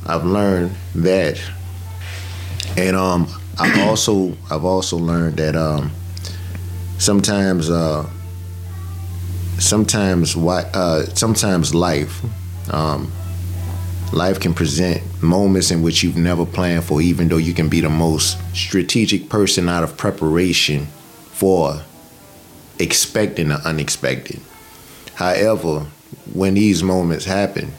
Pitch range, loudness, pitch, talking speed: 85-95 Hz, -18 LUFS, 90 Hz, 110 wpm